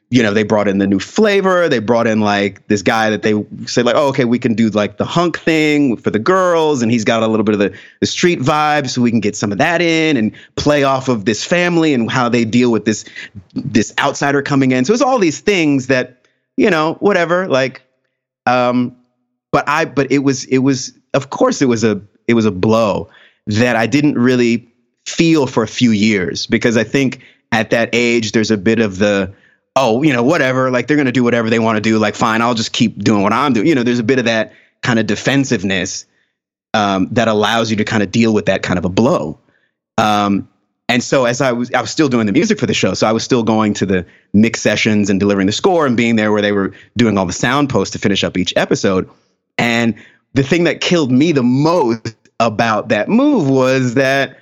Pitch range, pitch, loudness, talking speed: 110-135 Hz, 120 Hz, -14 LUFS, 235 wpm